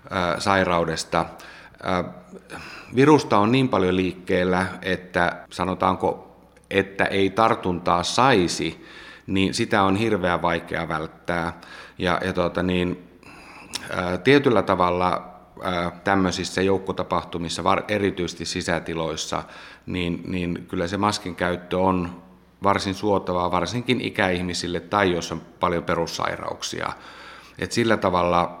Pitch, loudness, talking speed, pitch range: 90 Hz, -23 LUFS, 100 wpm, 85-95 Hz